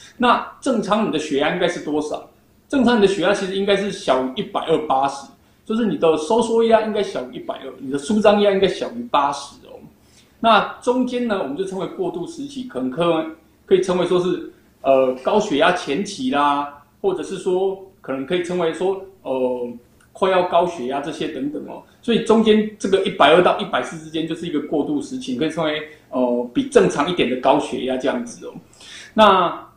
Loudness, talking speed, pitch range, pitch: -19 LUFS, 300 characters per minute, 150-220 Hz, 185 Hz